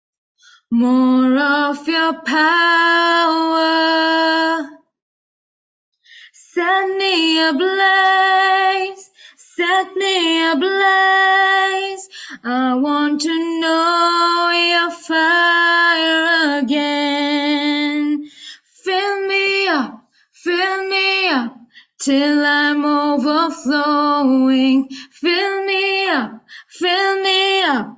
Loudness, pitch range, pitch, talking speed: -15 LUFS, 290-380 Hz, 330 Hz, 70 wpm